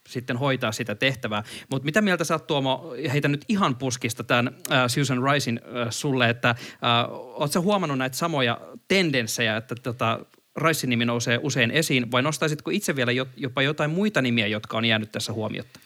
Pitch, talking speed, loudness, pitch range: 130 Hz, 180 wpm, -24 LUFS, 120-150 Hz